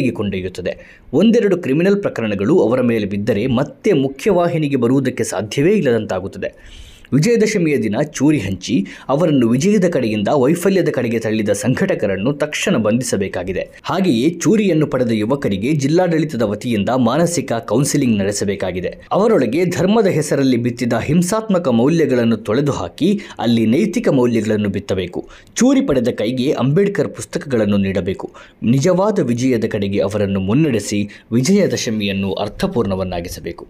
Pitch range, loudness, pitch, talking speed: 105-160 Hz, -17 LUFS, 125 Hz, 105 wpm